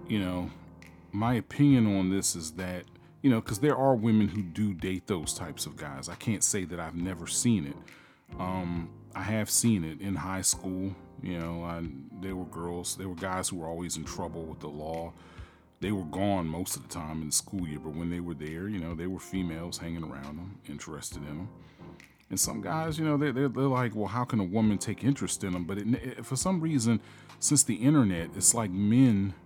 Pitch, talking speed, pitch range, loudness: 95 Hz, 225 wpm, 85-115 Hz, -30 LUFS